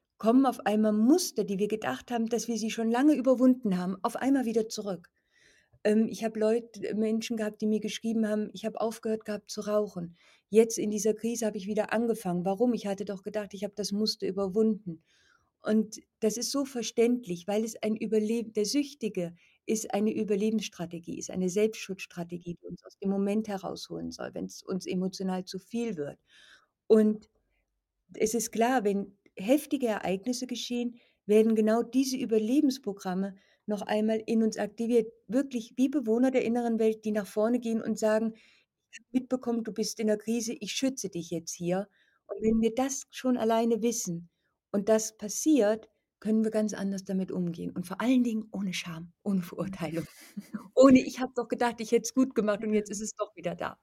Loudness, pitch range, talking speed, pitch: -29 LUFS, 200-230 Hz, 185 wpm, 215 Hz